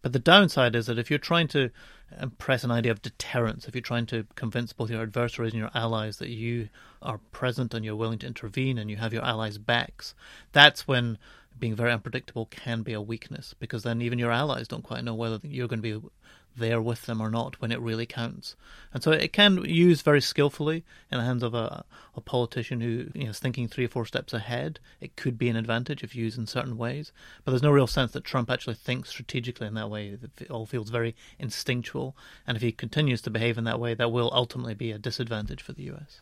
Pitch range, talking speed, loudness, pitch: 115-130 Hz, 235 wpm, -27 LUFS, 120 Hz